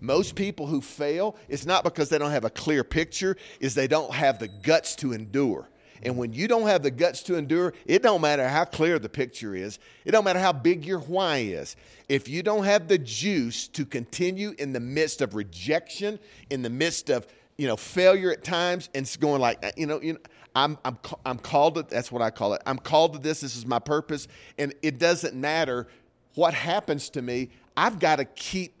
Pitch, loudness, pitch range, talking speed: 150 Hz, -26 LUFS, 130-175 Hz, 220 wpm